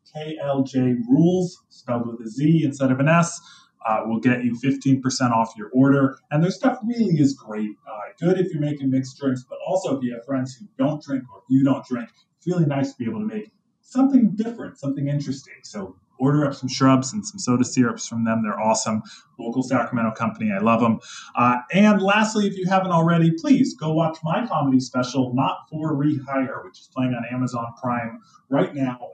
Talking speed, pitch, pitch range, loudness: 205 wpm, 135 Hz, 125-170 Hz, -22 LUFS